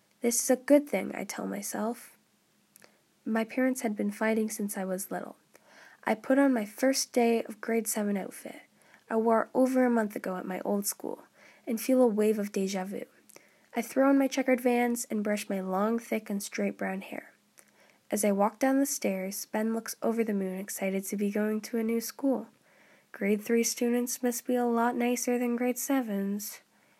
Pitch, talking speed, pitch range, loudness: 230 Hz, 200 wpm, 205-245 Hz, -29 LUFS